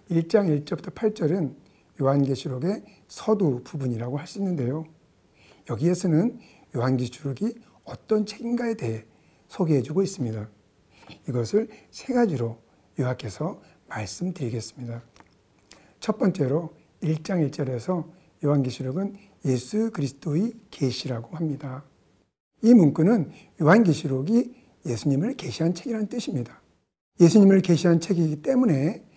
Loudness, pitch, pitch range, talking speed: -25 LUFS, 160 Hz, 130-200 Hz, 285 characters per minute